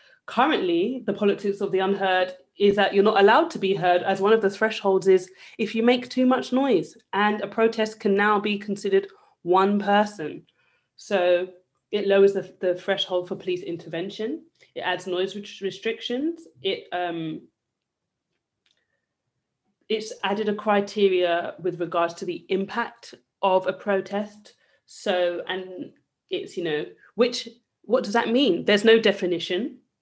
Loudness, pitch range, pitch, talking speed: -24 LUFS, 185-225 Hz, 200 Hz, 150 wpm